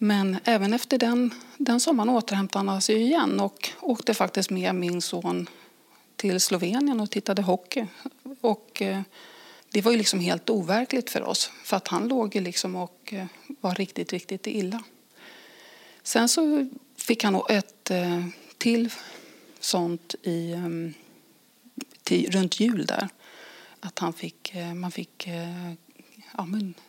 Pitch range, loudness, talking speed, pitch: 185-240 Hz, -26 LUFS, 130 wpm, 205 Hz